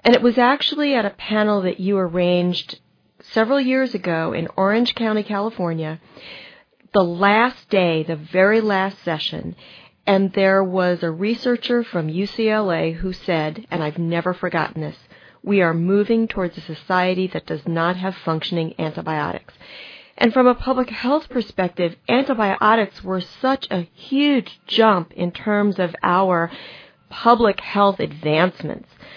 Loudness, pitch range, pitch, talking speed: -20 LUFS, 175-225 Hz, 195 Hz, 140 wpm